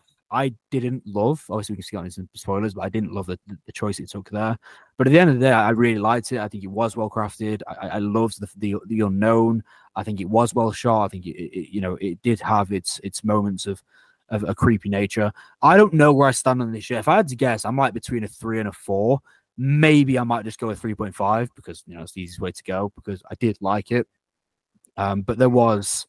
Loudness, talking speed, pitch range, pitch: -21 LUFS, 270 wpm, 100-120 Hz, 110 Hz